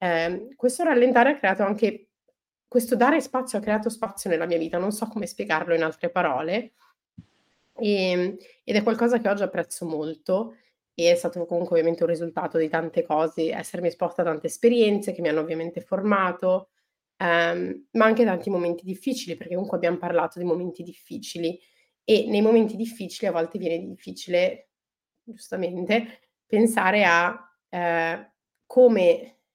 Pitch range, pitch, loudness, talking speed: 170-225 Hz, 180 Hz, -24 LUFS, 155 wpm